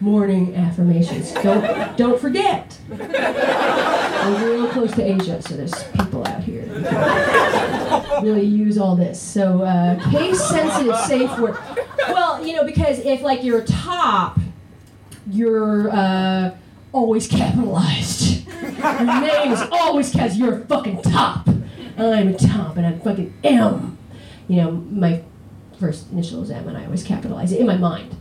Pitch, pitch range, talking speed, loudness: 210 Hz, 180-240 Hz, 145 wpm, -19 LUFS